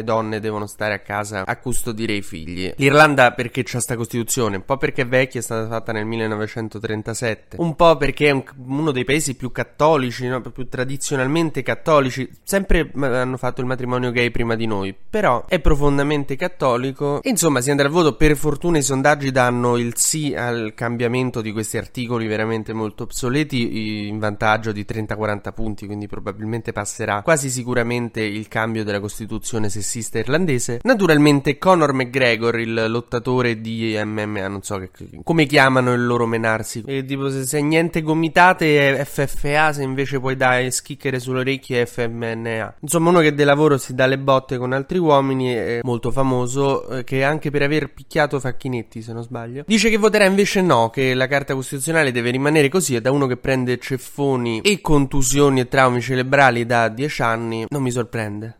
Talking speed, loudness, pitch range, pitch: 175 wpm, -19 LUFS, 115-145 Hz, 125 Hz